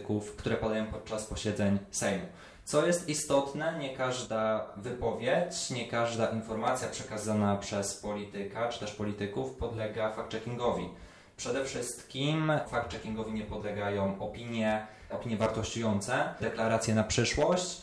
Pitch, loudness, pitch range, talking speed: 110 Hz, -33 LUFS, 105-120 Hz, 110 wpm